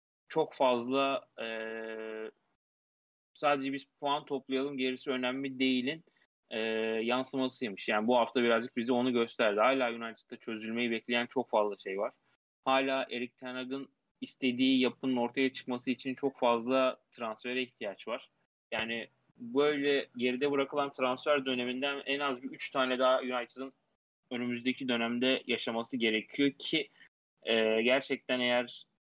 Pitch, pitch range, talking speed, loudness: 130 Hz, 120-135 Hz, 130 wpm, -32 LUFS